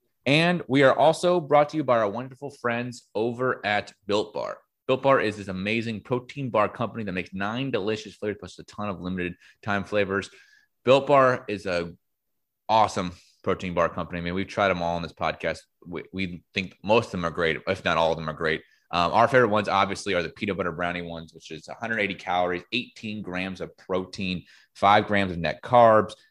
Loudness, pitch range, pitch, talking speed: -25 LUFS, 90-120 Hz, 105 Hz, 210 wpm